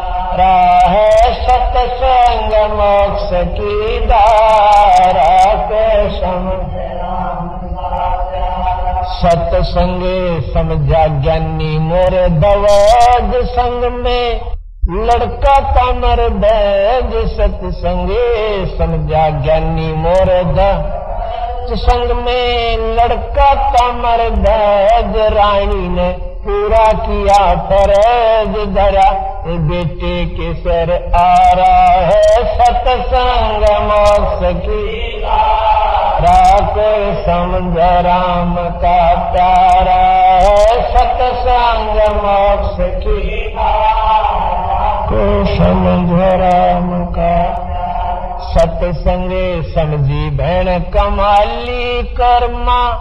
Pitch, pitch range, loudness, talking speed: 205 Hz, 180-240 Hz, -12 LUFS, 70 wpm